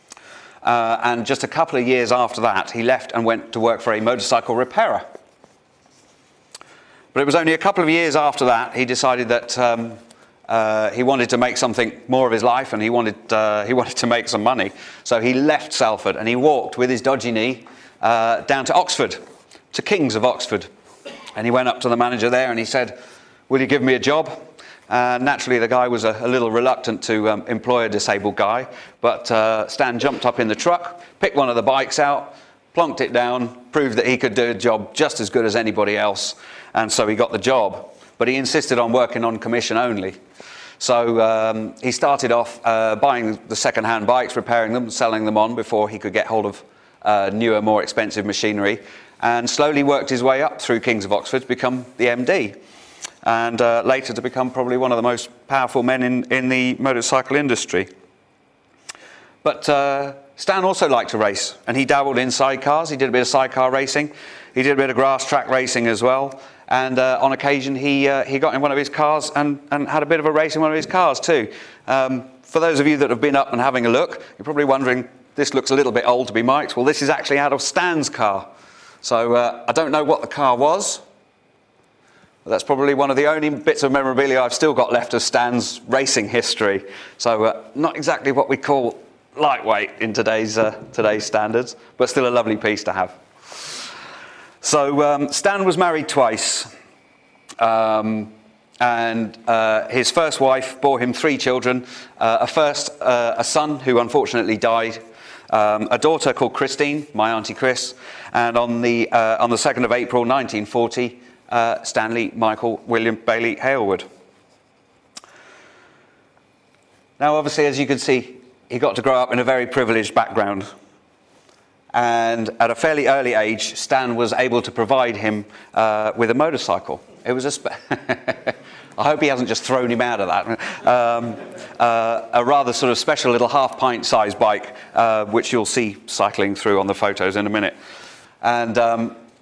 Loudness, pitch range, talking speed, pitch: -19 LUFS, 115-135 Hz, 200 wpm, 125 Hz